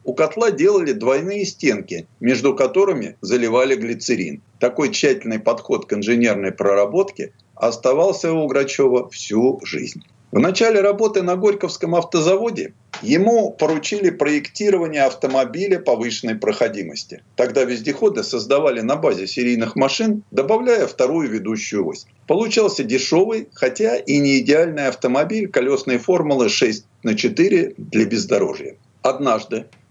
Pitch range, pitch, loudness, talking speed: 130-205 Hz, 160 Hz, -18 LUFS, 115 wpm